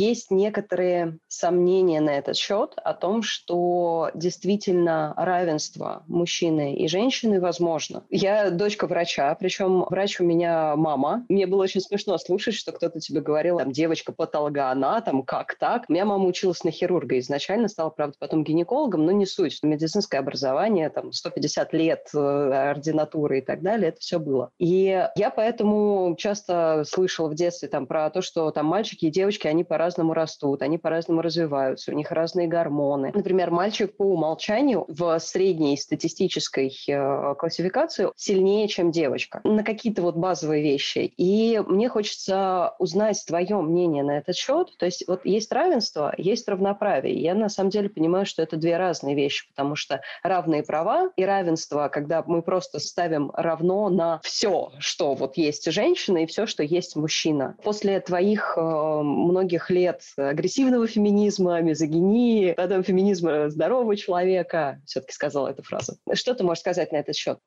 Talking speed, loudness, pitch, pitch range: 155 wpm, -24 LUFS, 175 Hz, 155-195 Hz